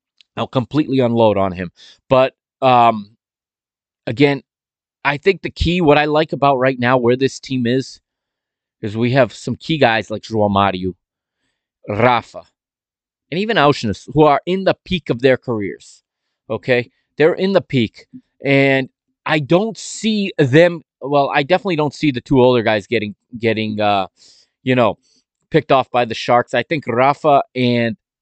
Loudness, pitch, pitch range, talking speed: -16 LUFS, 130 Hz, 115-150 Hz, 160 wpm